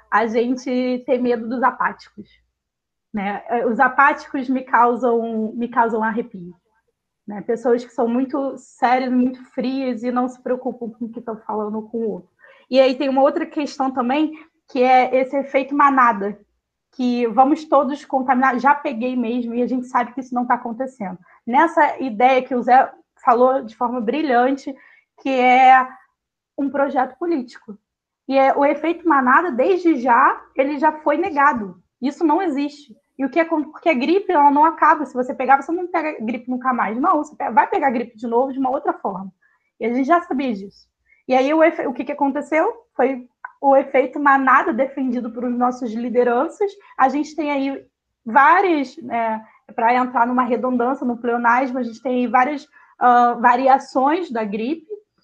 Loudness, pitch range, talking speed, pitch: -18 LUFS, 245-285 Hz, 175 wpm, 260 Hz